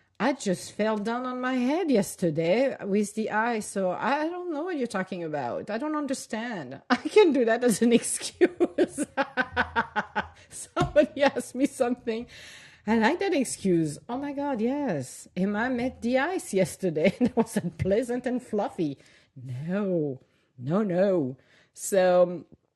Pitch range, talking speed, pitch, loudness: 185-265 Hz, 150 wpm, 225 Hz, -27 LUFS